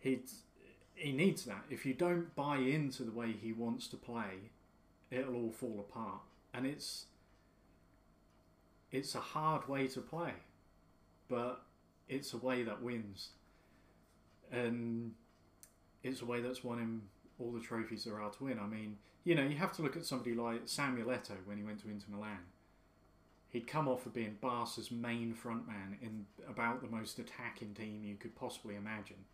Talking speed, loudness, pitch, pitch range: 170 wpm, -41 LUFS, 115 Hz, 100-125 Hz